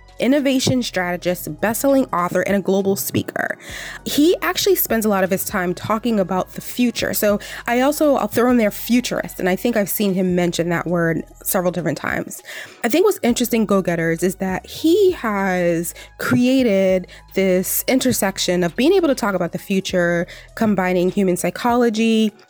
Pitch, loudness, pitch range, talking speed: 195 Hz, -19 LUFS, 180-240 Hz, 175 wpm